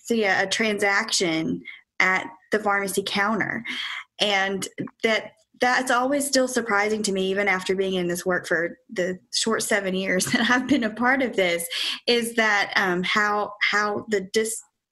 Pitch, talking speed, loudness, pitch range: 205 Hz, 155 wpm, -23 LUFS, 190-230 Hz